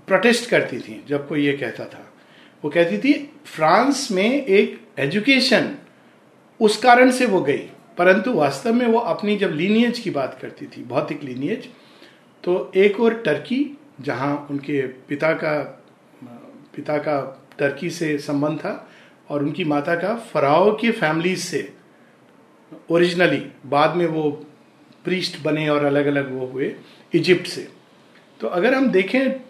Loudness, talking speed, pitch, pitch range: -20 LUFS, 145 wpm, 175 Hz, 145-230 Hz